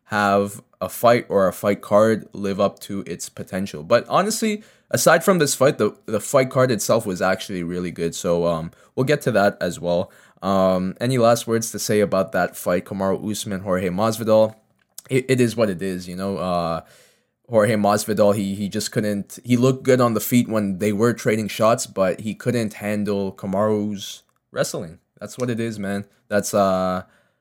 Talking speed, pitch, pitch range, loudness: 190 wpm, 105 Hz, 95-115 Hz, -21 LUFS